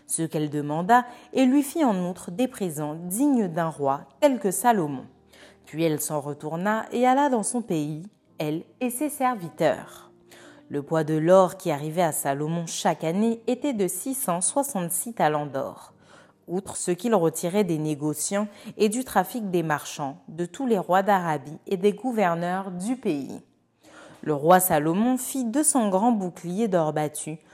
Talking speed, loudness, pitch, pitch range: 160 wpm, -25 LUFS, 185 Hz, 160-235 Hz